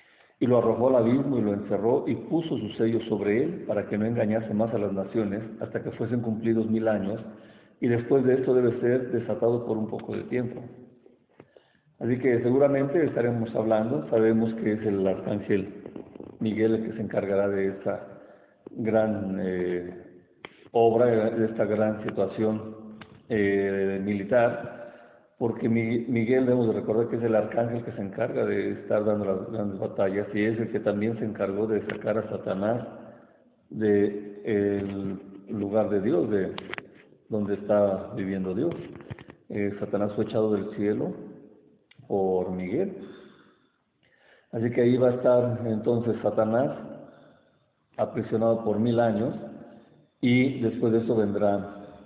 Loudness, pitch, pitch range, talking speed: -26 LUFS, 110 Hz, 100-115 Hz, 150 wpm